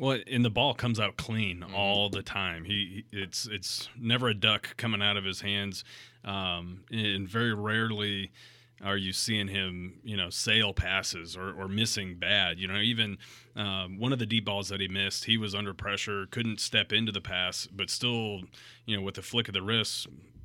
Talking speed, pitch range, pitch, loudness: 200 wpm, 95-115 Hz, 100 Hz, -30 LUFS